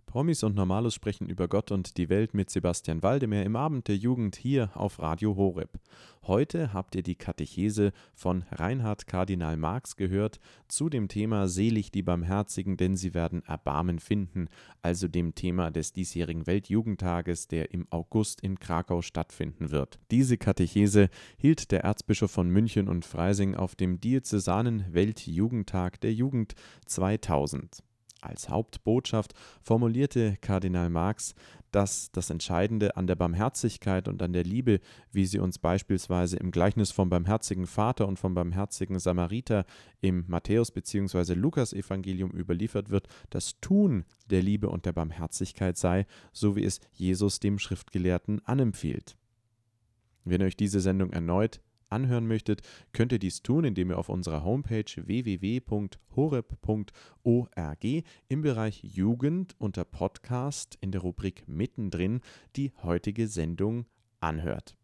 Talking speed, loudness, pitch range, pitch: 140 wpm, -30 LUFS, 90-110 Hz, 100 Hz